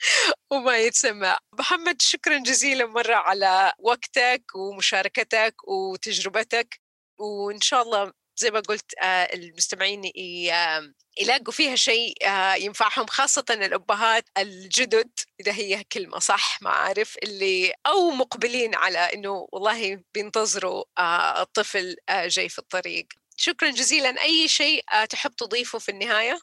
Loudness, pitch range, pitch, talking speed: -22 LUFS, 195-260 Hz, 220 Hz, 110 wpm